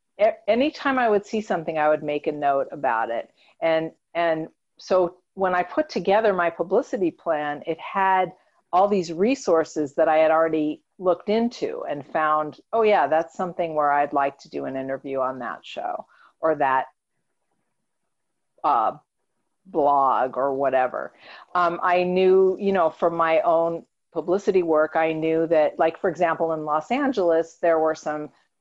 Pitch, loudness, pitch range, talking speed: 165 Hz, -23 LUFS, 155-185 Hz, 160 wpm